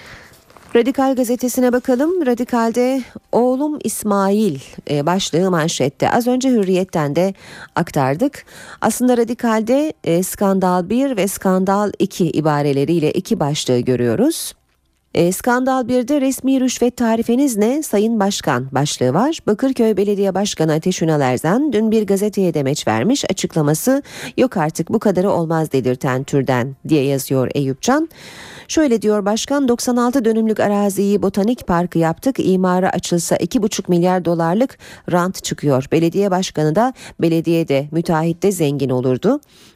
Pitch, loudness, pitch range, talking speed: 195 Hz, -17 LUFS, 160-240 Hz, 120 wpm